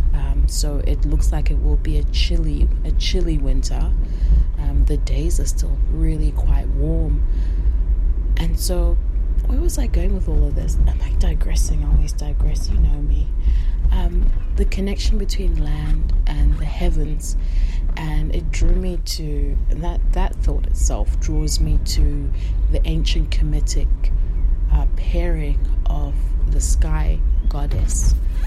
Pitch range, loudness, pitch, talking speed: 70-80 Hz, -22 LUFS, 75 Hz, 145 wpm